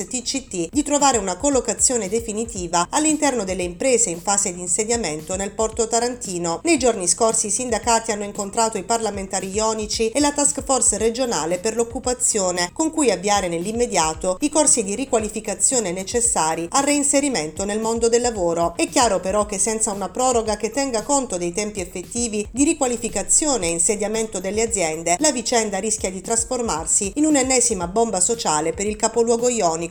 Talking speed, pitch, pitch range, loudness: 160 wpm, 225 Hz, 190-245 Hz, -20 LUFS